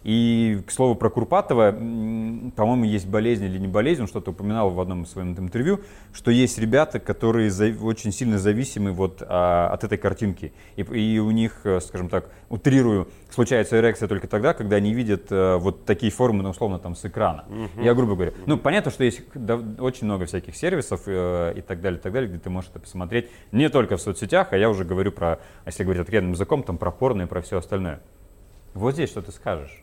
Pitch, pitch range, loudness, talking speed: 105 Hz, 95-115 Hz, -23 LUFS, 195 wpm